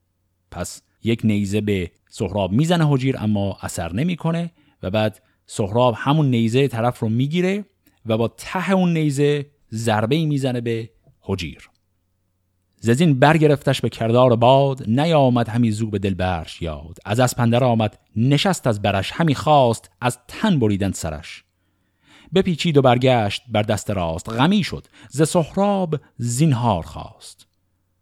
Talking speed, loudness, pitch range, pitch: 140 wpm, -20 LUFS, 95-140 Hz, 115 Hz